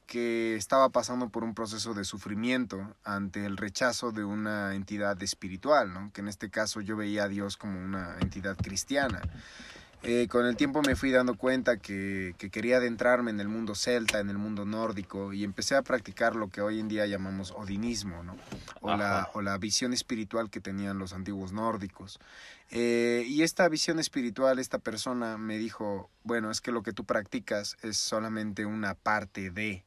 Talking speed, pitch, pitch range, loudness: 185 wpm, 105 Hz, 100-120 Hz, -31 LUFS